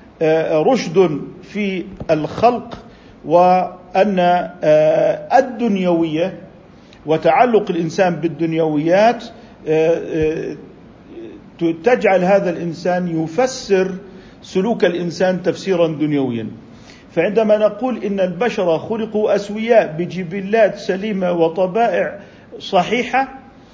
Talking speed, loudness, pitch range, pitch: 65 wpm, -17 LUFS, 165-220 Hz, 185 Hz